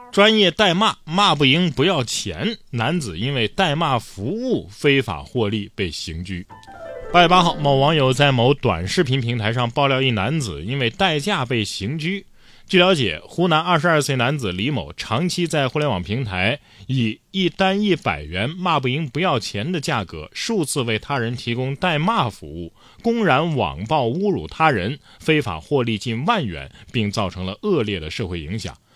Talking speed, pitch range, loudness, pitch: 260 characters per minute, 110-170 Hz, -20 LUFS, 135 Hz